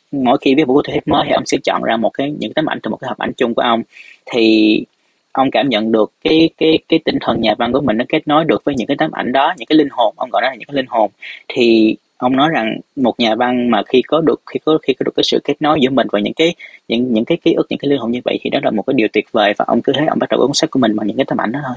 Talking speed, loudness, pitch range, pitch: 340 wpm, -15 LUFS, 115-155 Hz, 130 Hz